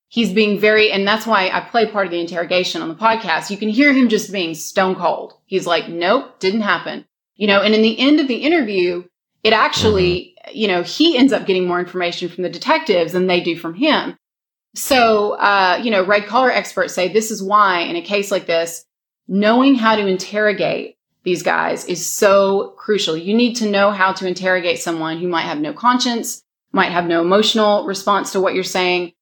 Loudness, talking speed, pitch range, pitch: -16 LUFS, 210 wpm, 180-220 Hz, 200 Hz